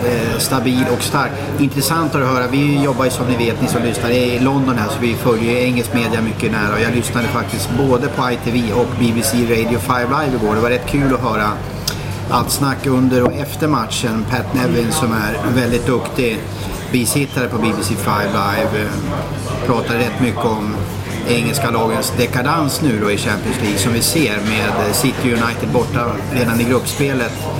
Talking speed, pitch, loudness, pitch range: 185 wpm, 120 Hz, -16 LUFS, 115-130 Hz